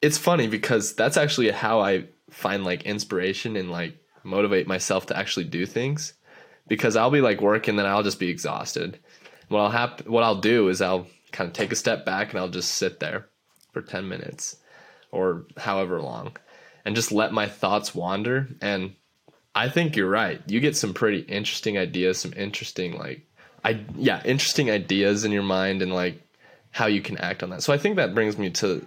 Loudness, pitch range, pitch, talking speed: -24 LUFS, 95-120 Hz, 105 Hz, 200 wpm